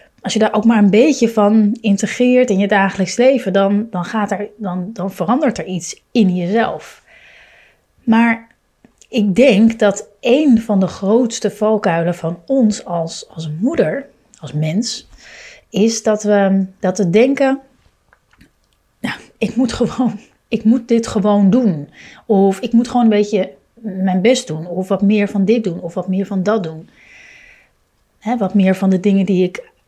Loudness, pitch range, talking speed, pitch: -15 LUFS, 190-230 Hz, 170 wpm, 210 Hz